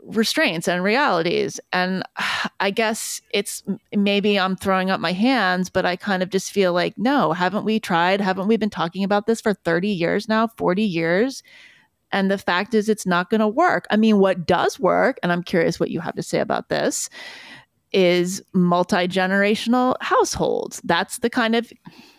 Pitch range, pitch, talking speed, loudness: 185-225 Hz, 200 Hz, 185 wpm, -20 LUFS